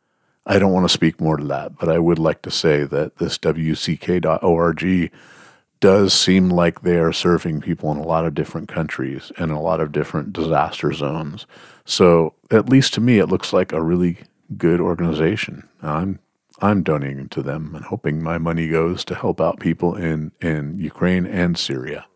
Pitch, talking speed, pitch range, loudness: 85 Hz, 185 wpm, 80-90 Hz, -19 LUFS